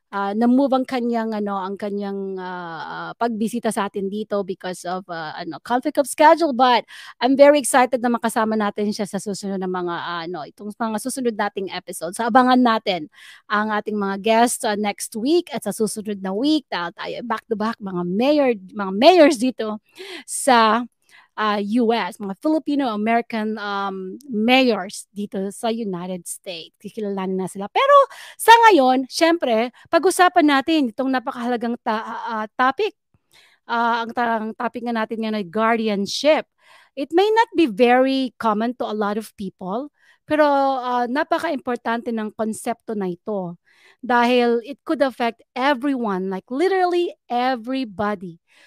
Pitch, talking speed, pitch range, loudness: 230 Hz, 155 wpm, 205-260 Hz, -20 LUFS